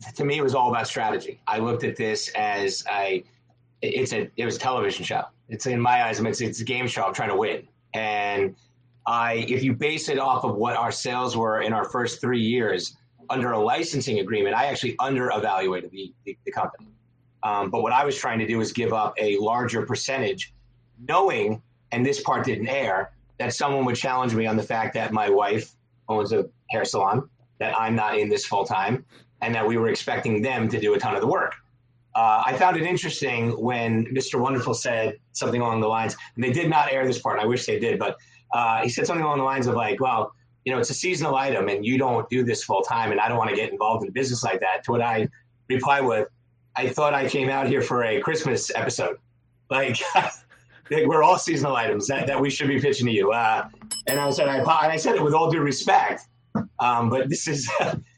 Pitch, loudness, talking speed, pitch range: 125 Hz, -24 LUFS, 225 wpm, 115-135 Hz